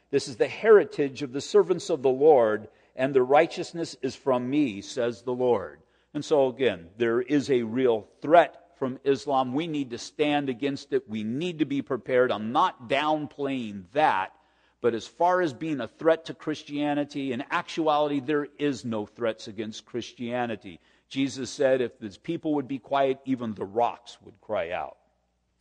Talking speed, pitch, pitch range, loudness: 175 wpm, 135 Hz, 120-155 Hz, -26 LUFS